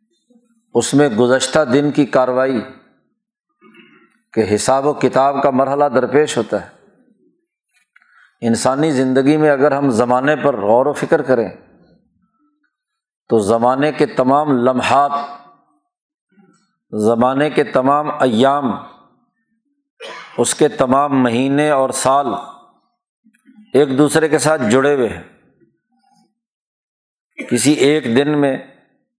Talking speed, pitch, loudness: 105 wpm, 145 Hz, -15 LUFS